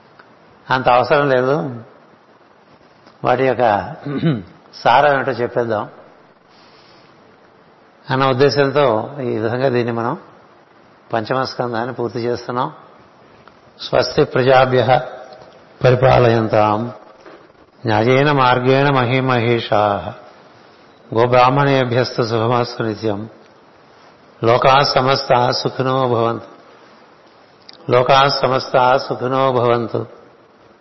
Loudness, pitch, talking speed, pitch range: -16 LUFS, 125 Hz, 65 wpm, 115-130 Hz